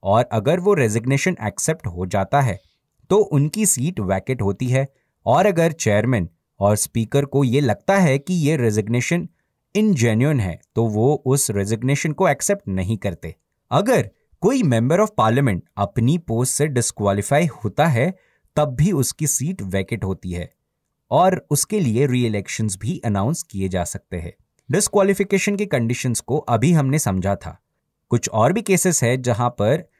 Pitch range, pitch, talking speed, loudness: 105-155 Hz, 125 Hz, 160 wpm, -20 LUFS